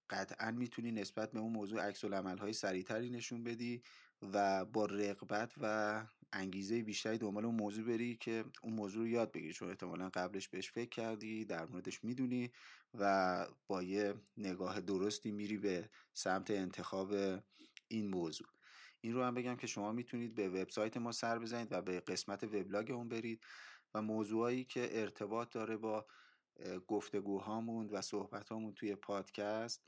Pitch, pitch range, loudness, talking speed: 105 Hz, 100-115 Hz, -42 LUFS, 155 wpm